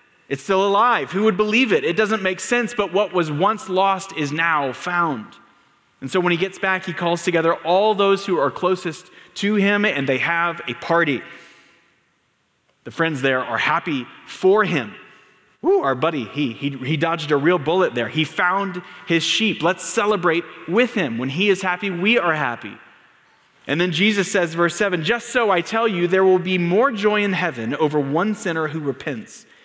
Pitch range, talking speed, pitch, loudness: 165-205 Hz, 195 wpm, 180 Hz, -20 LUFS